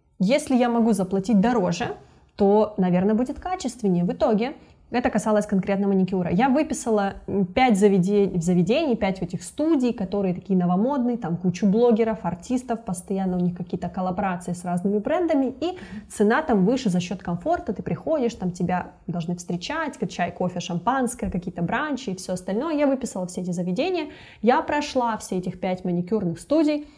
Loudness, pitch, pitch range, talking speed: -24 LUFS, 205 Hz, 185-245 Hz, 160 wpm